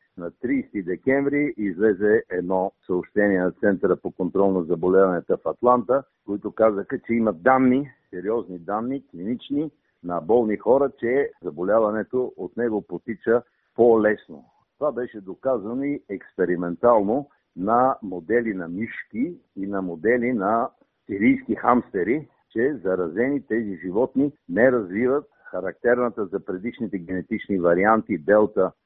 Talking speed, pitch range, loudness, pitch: 125 wpm, 95-130 Hz, -23 LUFS, 110 Hz